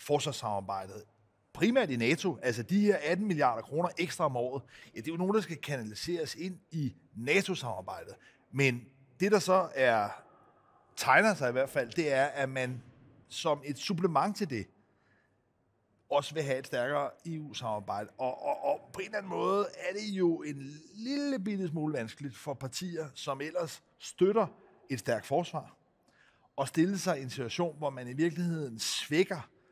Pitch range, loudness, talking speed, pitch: 130-175 Hz, -32 LUFS, 170 wpm, 145 Hz